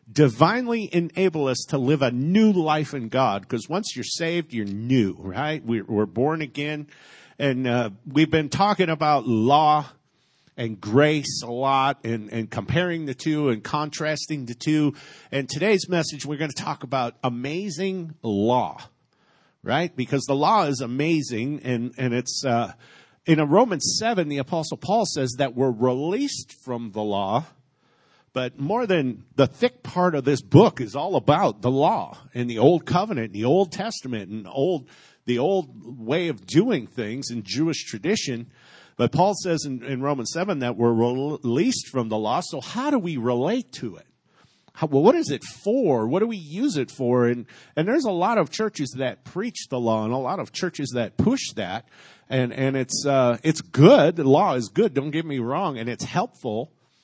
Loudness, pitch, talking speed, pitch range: -23 LUFS, 140 Hz, 190 wpm, 125-160 Hz